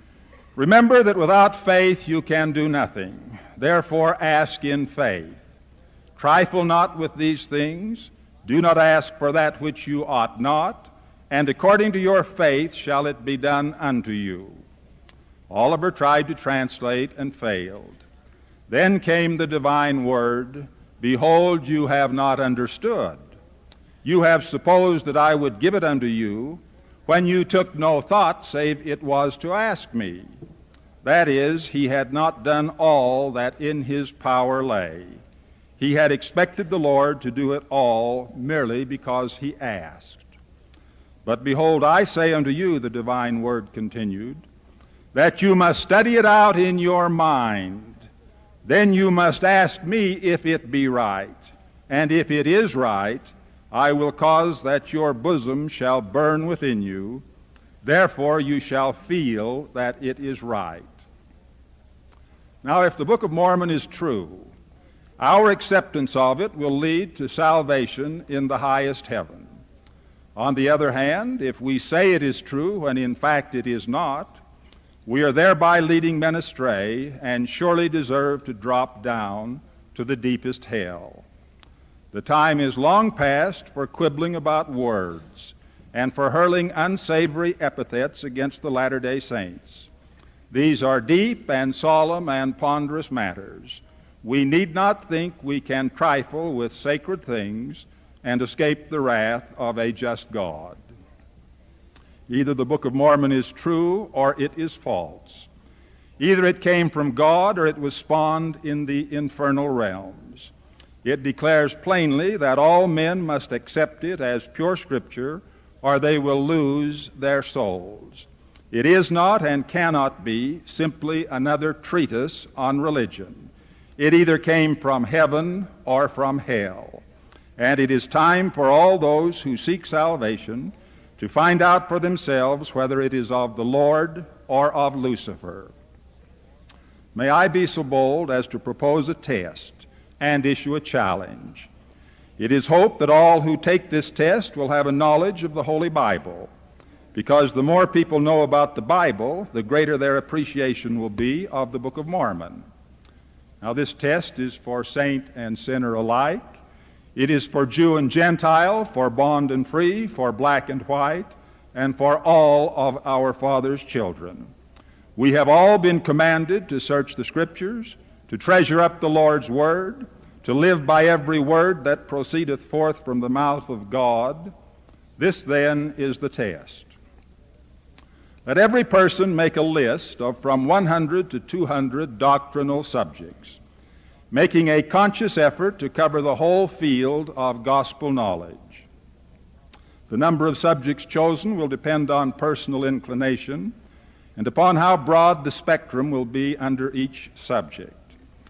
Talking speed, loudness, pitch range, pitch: 150 wpm, -20 LUFS, 115-160 Hz, 140 Hz